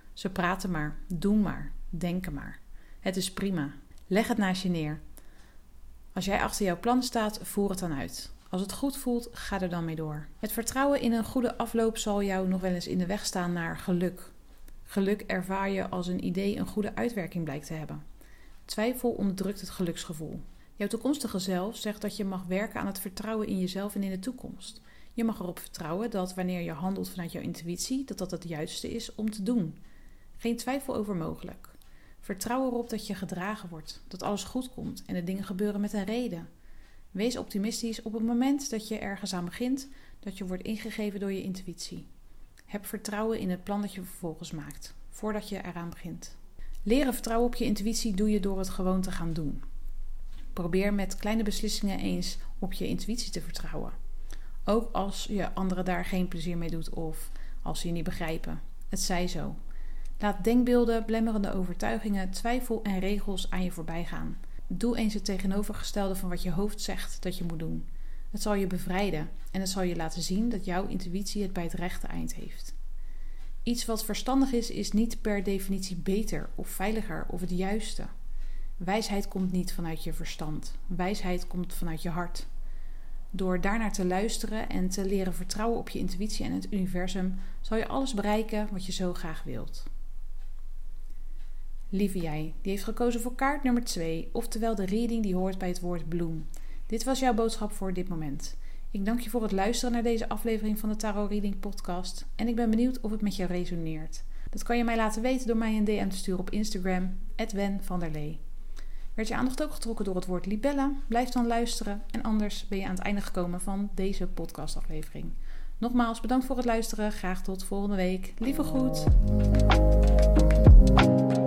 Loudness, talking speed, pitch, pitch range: -31 LUFS, 190 wpm, 195 Hz, 180-220 Hz